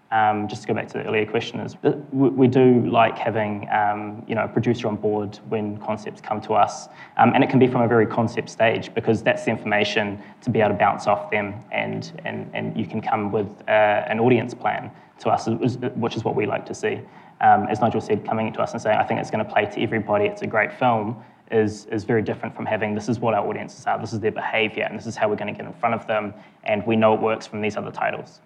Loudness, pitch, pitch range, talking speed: -22 LUFS, 110 Hz, 105-115 Hz, 265 wpm